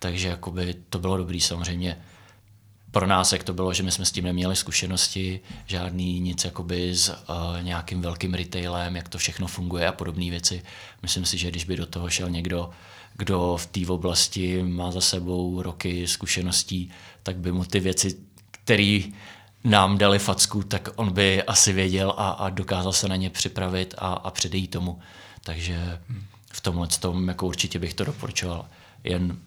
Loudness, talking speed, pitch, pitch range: -25 LUFS, 175 wpm, 90 Hz, 90-100 Hz